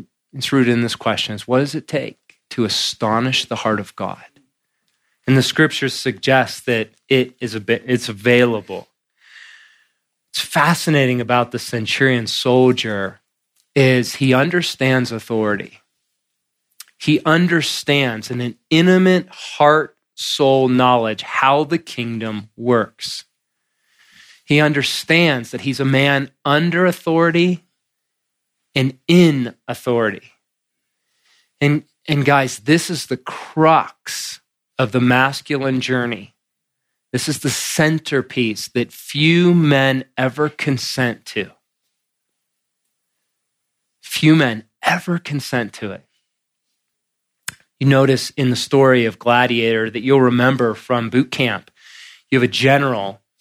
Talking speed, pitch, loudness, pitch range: 115 wpm, 130 Hz, -17 LUFS, 120-145 Hz